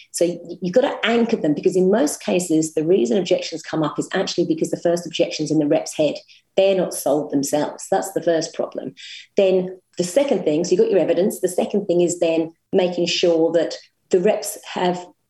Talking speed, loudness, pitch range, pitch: 210 wpm, -20 LUFS, 165-195 Hz, 175 Hz